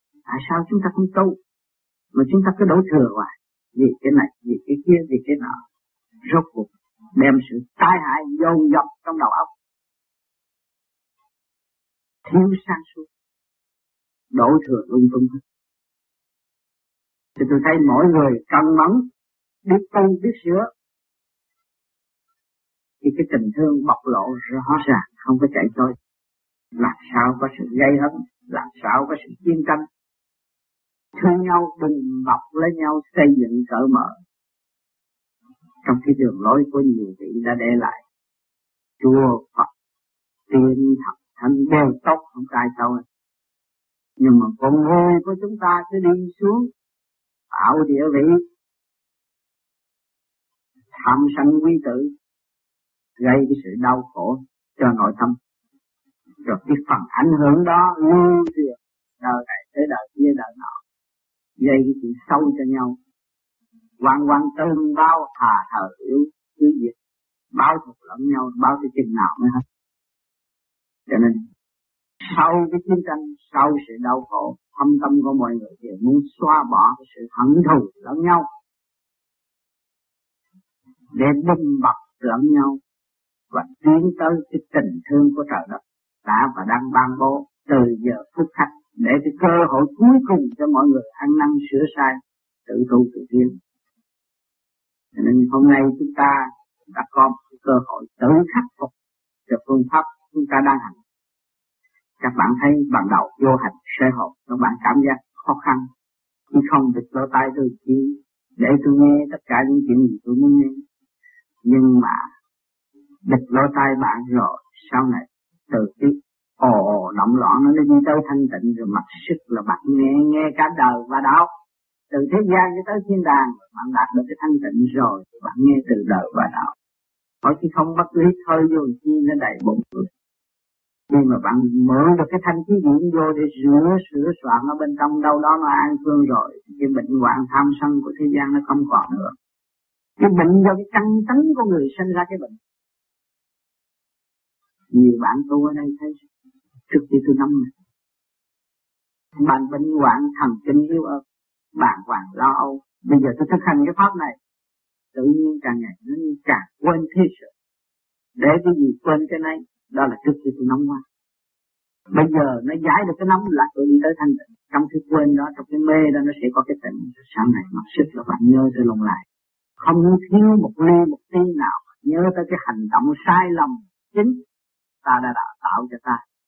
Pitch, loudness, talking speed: 175 Hz, -18 LUFS, 170 wpm